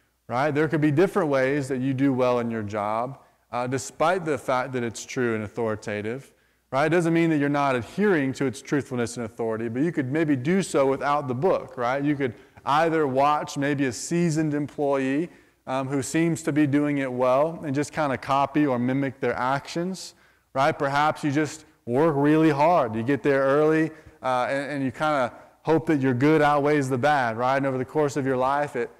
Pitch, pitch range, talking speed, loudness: 140 Hz, 130-155 Hz, 215 wpm, -24 LUFS